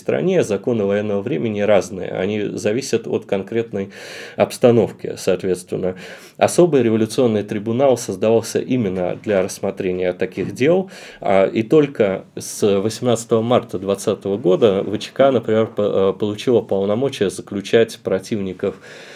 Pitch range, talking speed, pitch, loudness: 100-115 Hz, 105 wpm, 110 Hz, -19 LUFS